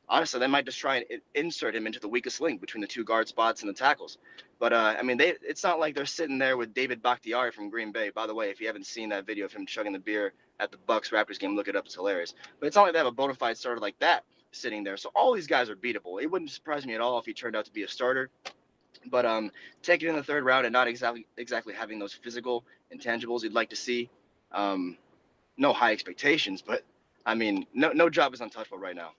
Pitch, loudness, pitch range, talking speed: 125 Hz, -29 LUFS, 115-165 Hz, 265 wpm